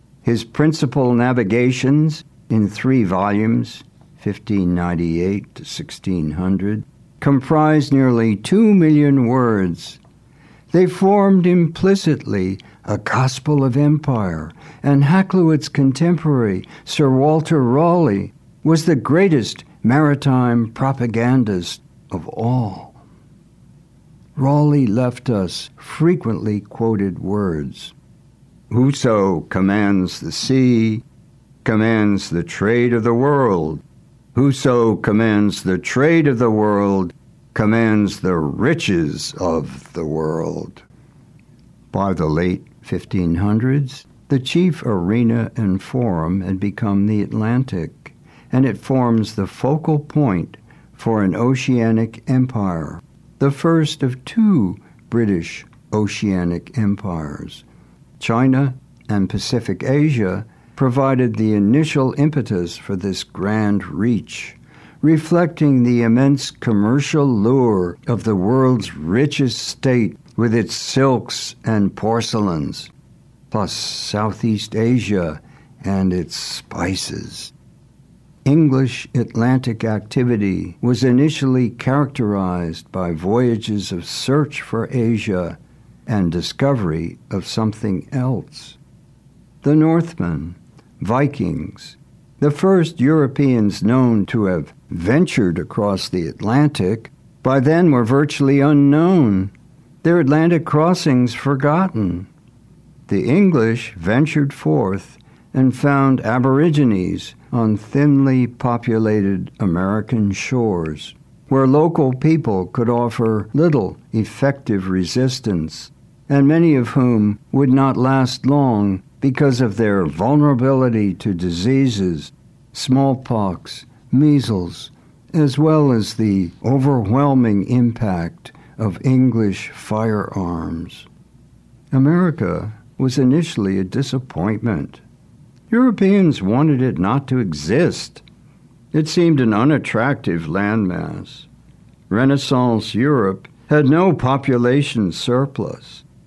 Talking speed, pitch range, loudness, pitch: 95 wpm, 105-140 Hz, -17 LUFS, 125 Hz